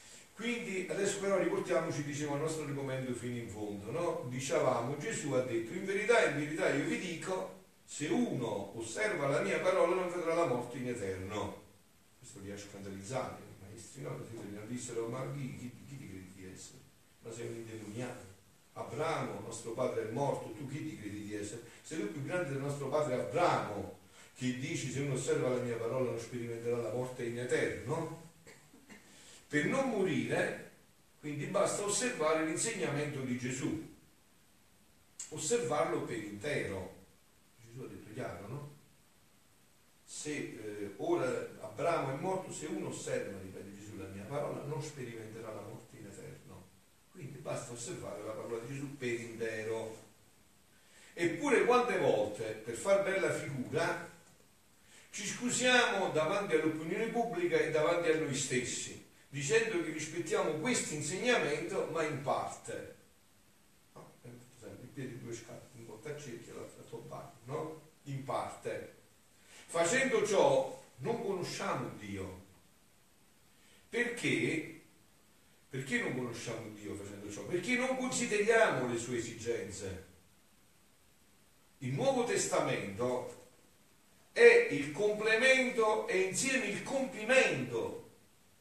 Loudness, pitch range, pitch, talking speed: -35 LUFS, 115-175 Hz, 140 Hz, 135 wpm